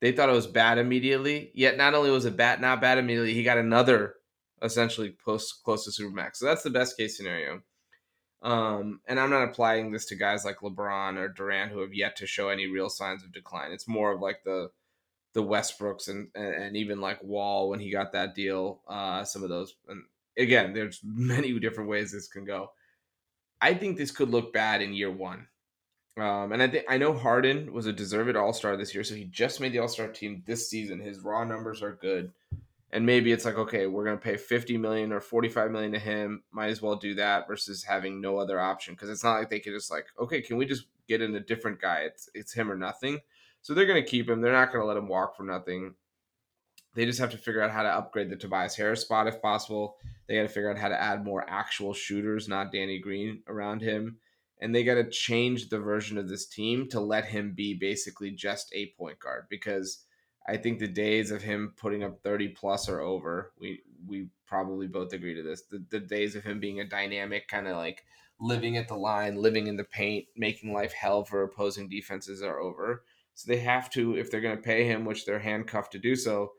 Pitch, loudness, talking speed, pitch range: 105 Hz, -29 LUFS, 230 wpm, 100-115 Hz